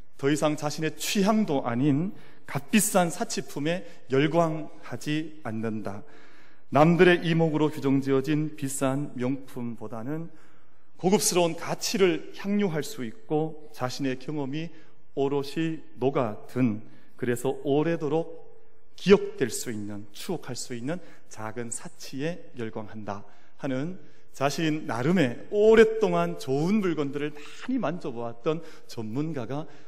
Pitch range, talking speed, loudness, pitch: 130-165 Hz, 255 characters per minute, -27 LUFS, 150 Hz